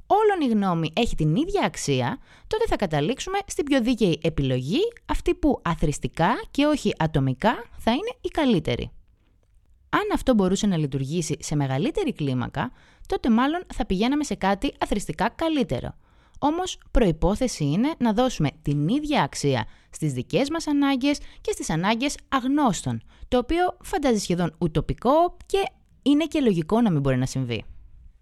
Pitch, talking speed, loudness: 220 Hz, 150 wpm, -24 LUFS